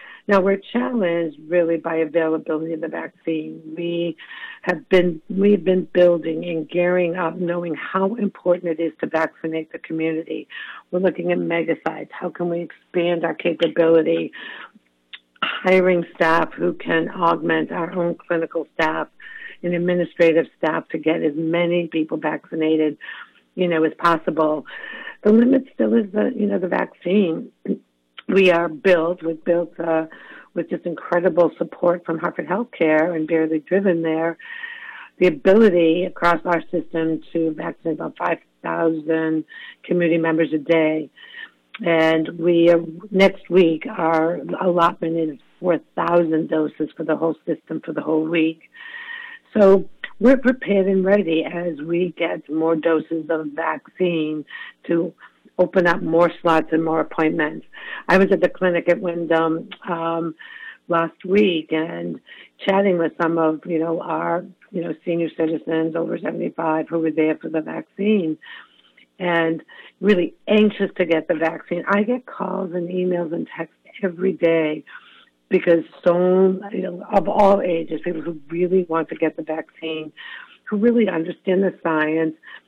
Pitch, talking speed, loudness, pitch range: 170 Hz, 145 wpm, -20 LUFS, 160-185 Hz